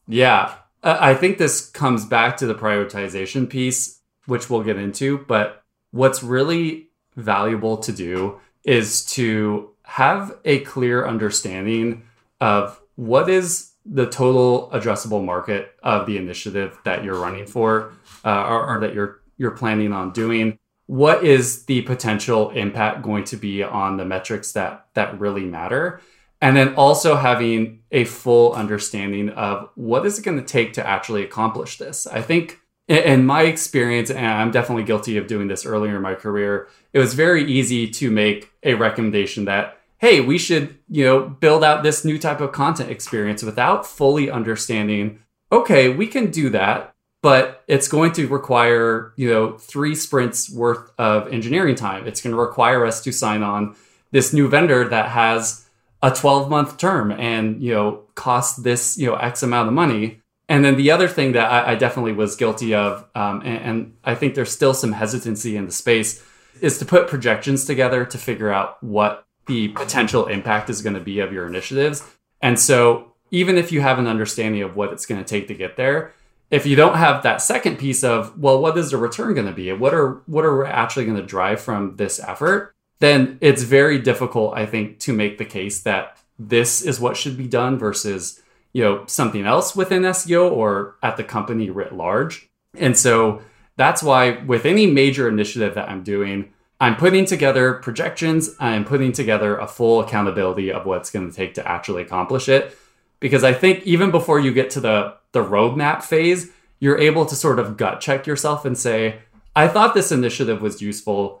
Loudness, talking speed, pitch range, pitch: -19 LUFS, 185 wpm, 105-135 Hz, 115 Hz